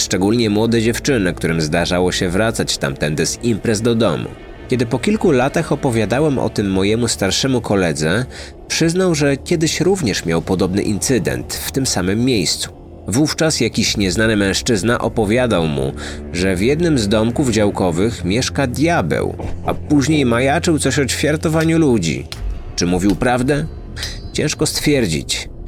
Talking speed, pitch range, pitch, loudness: 140 wpm, 95-140 Hz, 115 Hz, -17 LUFS